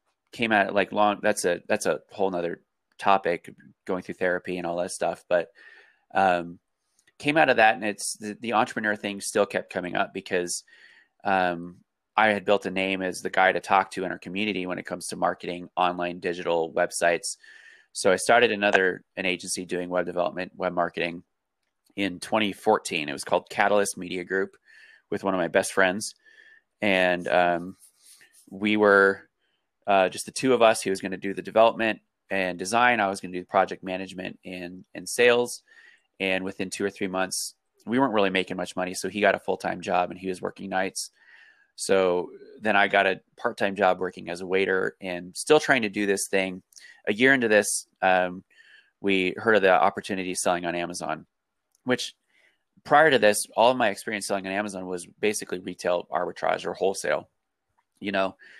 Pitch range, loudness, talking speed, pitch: 90-105 Hz, -25 LUFS, 195 wpm, 95 Hz